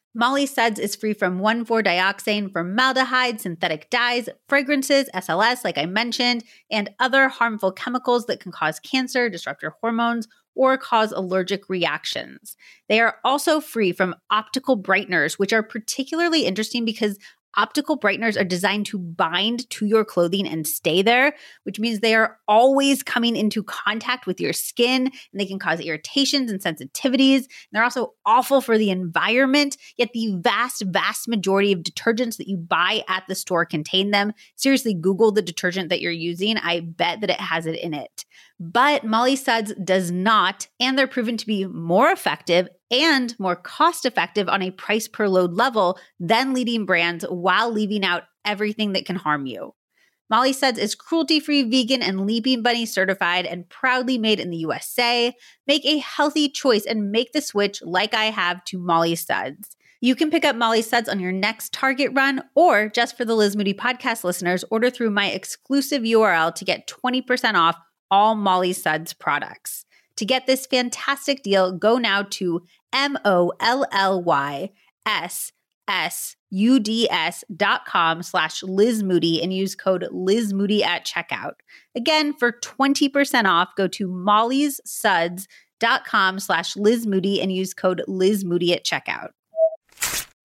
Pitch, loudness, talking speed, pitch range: 215 Hz, -21 LUFS, 160 wpm, 185-250 Hz